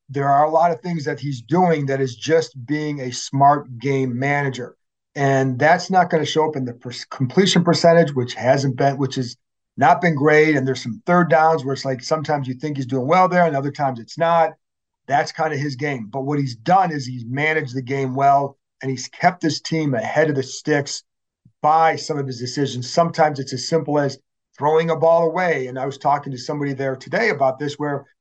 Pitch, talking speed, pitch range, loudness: 145 Hz, 225 wpm, 130-160 Hz, -19 LUFS